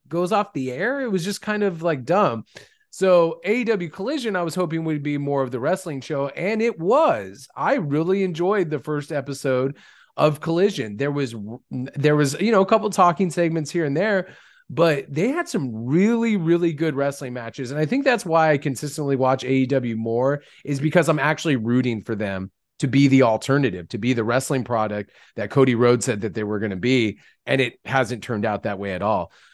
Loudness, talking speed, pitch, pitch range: -22 LUFS, 205 wpm, 145 Hz, 125-175 Hz